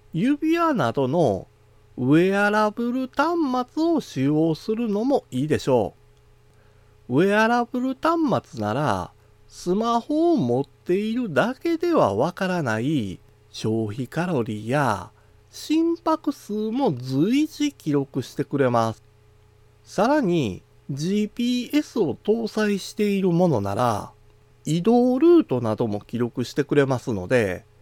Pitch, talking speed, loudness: 160 Hz, 235 characters per minute, -23 LUFS